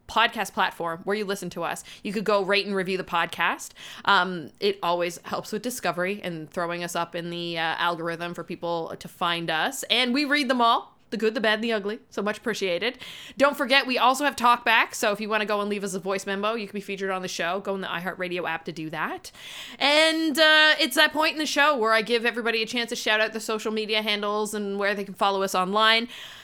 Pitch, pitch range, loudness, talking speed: 205 Hz, 180-235 Hz, -24 LUFS, 250 wpm